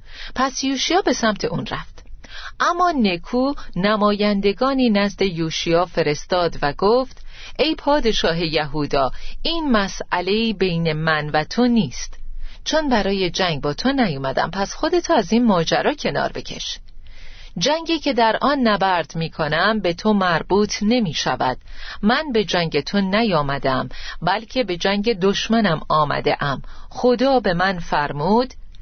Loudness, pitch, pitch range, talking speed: -20 LUFS, 205 Hz, 175-245 Hz, 130 wpm